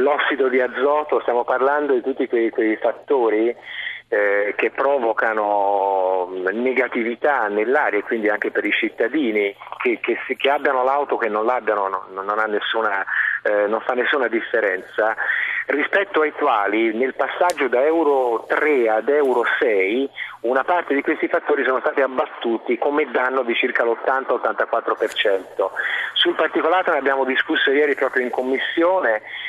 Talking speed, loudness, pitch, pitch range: 150 wpm, -20 LUFS, 130 Hz, 110-150 Hz